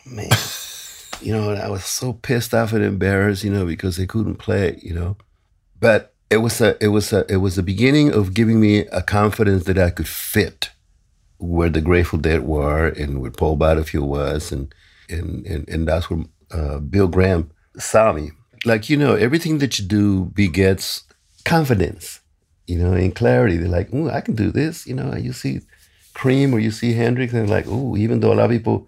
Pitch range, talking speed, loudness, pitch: 85-115 Hz, 200 wpm, -19 LUFS, 100 Hz